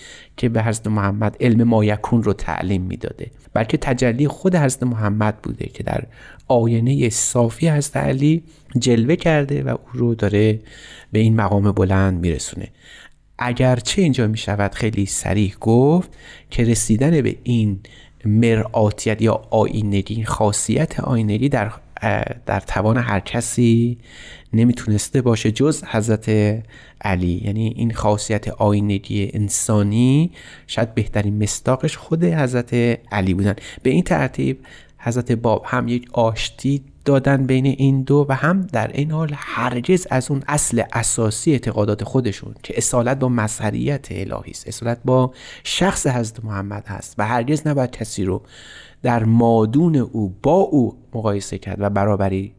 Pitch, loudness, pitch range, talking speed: 115 Hz, -19 LUFS, 105-130 Hz, 135 wpm